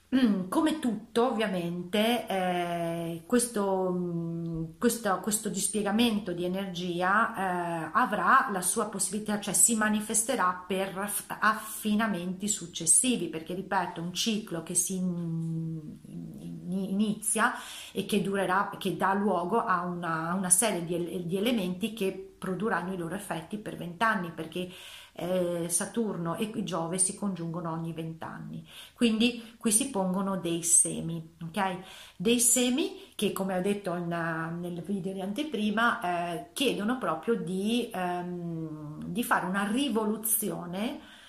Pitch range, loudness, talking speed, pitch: 175-215 Hz, -29 LUFS, 125 wpm, 190 Hz